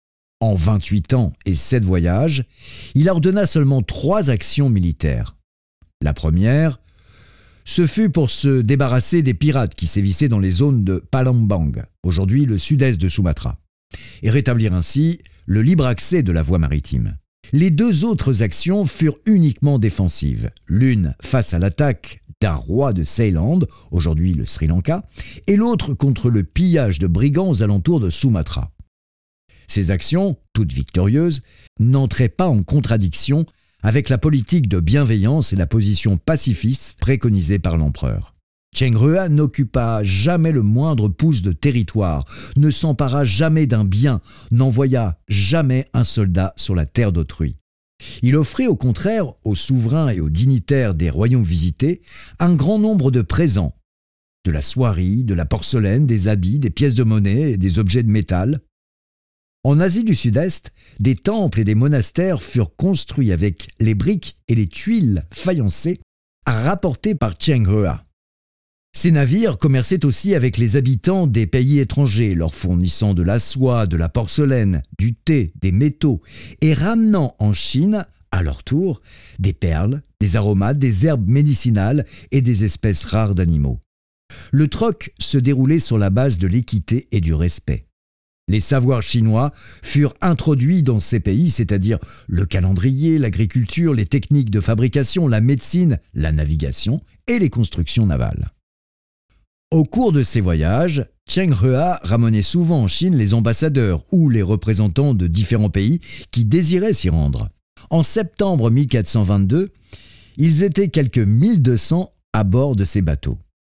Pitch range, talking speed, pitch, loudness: 95-145 Hz, 150 wpm, 115 Hz, -18 LUFS